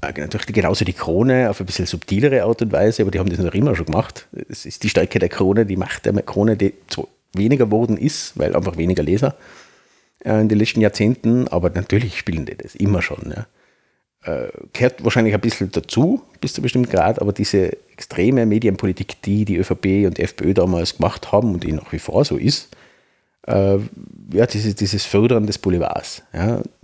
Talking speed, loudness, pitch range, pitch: 190 wpm, -19 LUFS, 95-115 Hz, 100 Hz